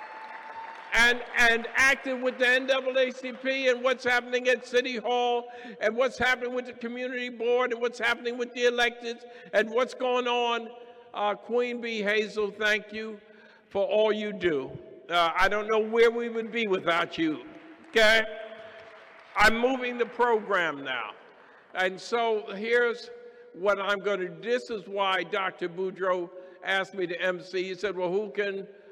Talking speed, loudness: 160 wpm, -27 LUFS